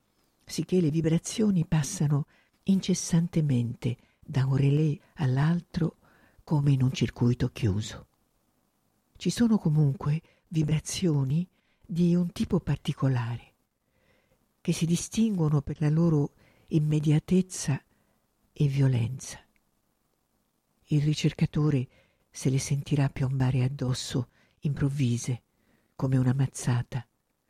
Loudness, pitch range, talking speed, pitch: -28 LUFS, 130-165 Hz, 90 wpm, 150 Hz